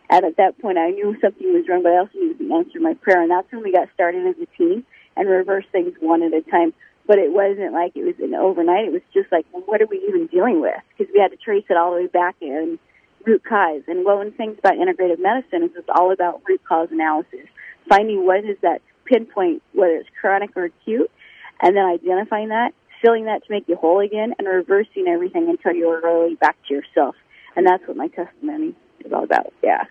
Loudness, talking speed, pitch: -19 LUFS, 240 wpm, 200 Hz